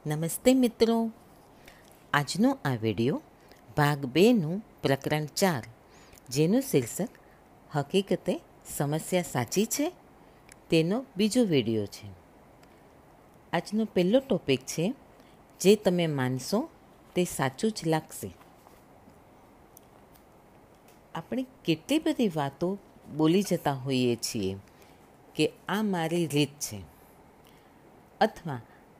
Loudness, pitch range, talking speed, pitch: -28 LUFS, 130-200 Hz, 90 wpm, 160 Hz